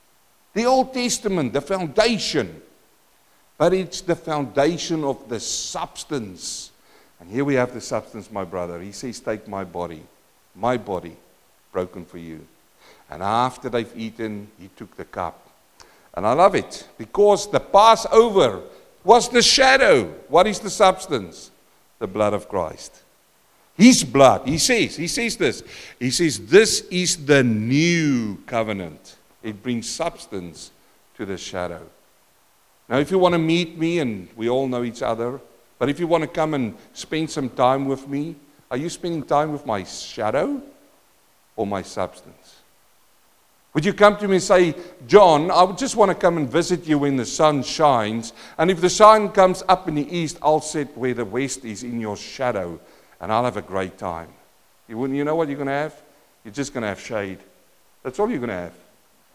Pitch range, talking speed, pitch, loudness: 115-180 Hz, 175 wpm, 145 Hz, -20 LUFS